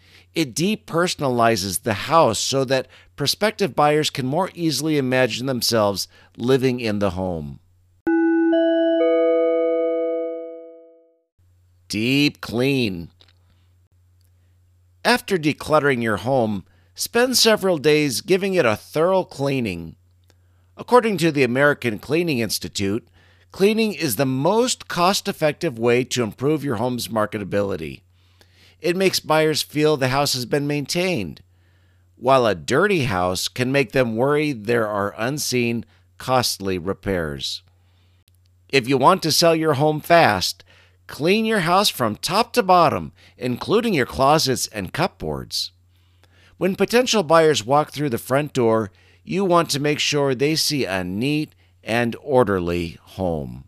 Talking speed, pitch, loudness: 125 wpm, 130 Hz, -20 LUFS